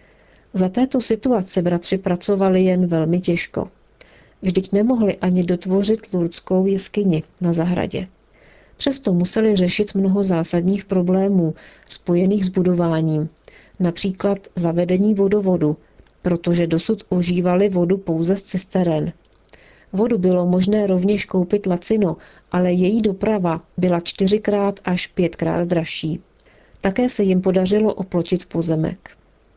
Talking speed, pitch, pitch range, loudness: 110 wpm, 185 Hz, 175-200 Hz, -19 LUFS